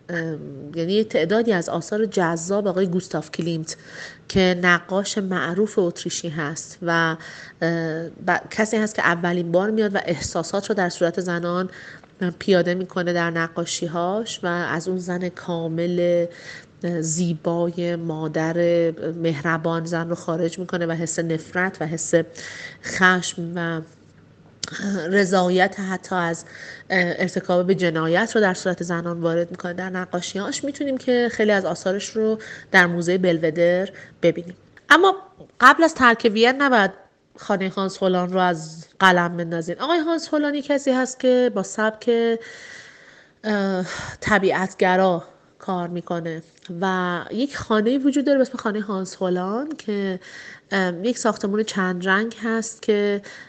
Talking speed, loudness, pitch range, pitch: 130 wpm, -22 LUFS, 170-210 Hz, 185 Hz